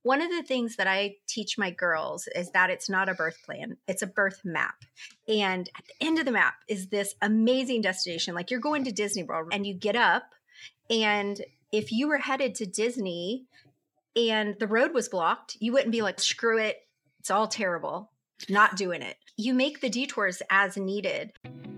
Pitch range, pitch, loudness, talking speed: 195-250 Hz, 215 Hz, -27 LUFS, 195 wpm